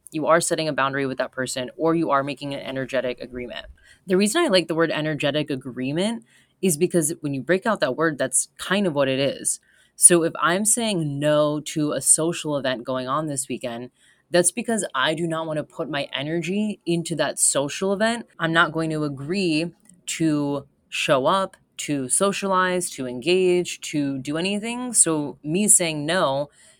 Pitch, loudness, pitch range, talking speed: 160 Hz, -22 LUFS, 140-180 Hz, 185 wpm